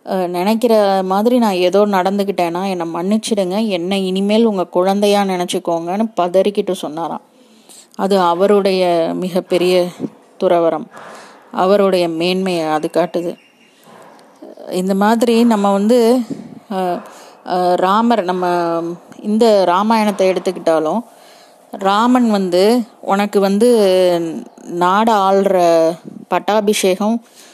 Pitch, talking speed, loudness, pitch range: 195 Hz, 80 wpm, -15 LUFS, 180-220 Hz